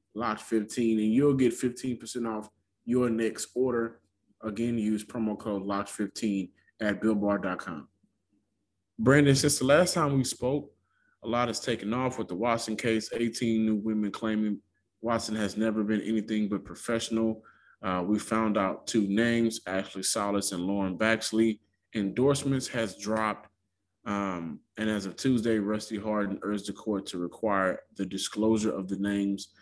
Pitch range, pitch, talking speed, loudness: 100-115 Hz, 110 Hz, 155 wpm, -29 LUFS